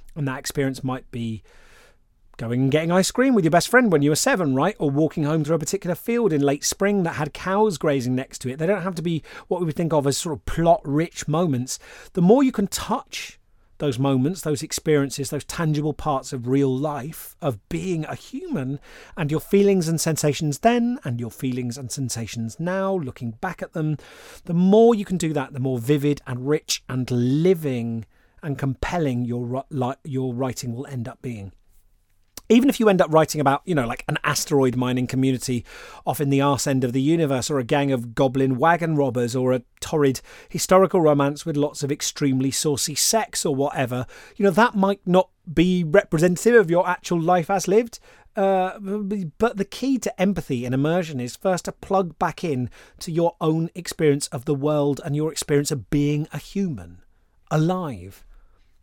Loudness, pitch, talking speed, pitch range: -22 LUFS, 150 Hz, 195 wpm, 130-180 Hz